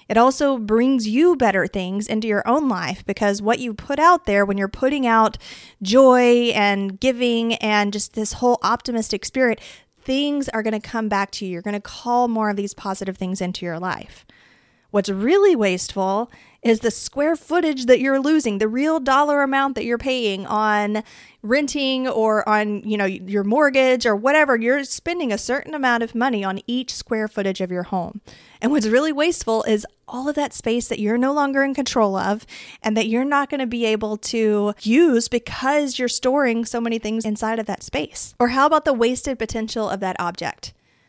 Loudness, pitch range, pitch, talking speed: -20 LUFS, 210-265 Hz, 230 Hz, 195 wpm